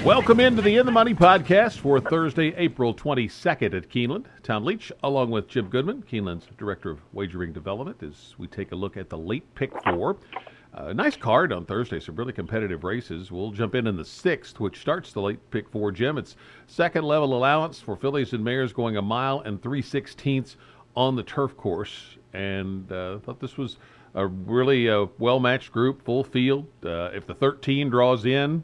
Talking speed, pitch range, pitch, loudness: 195 wpm, 100-140 Hz, 125 Hz, -24 LUFS